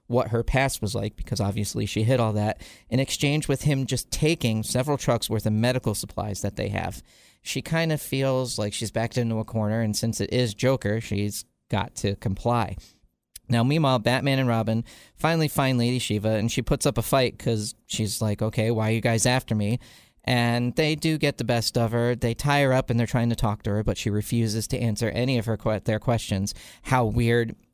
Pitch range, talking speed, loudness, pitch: 110-130 Hz, 220 wpm, -25 LUFS, 115 Hz